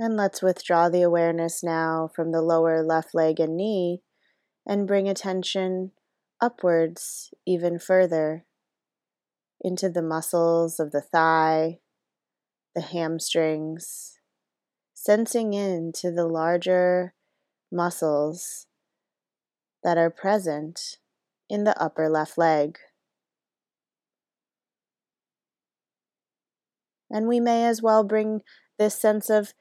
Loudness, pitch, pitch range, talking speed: -24 LUFS, 175 Hz, 165-200 Hz, 100 wpm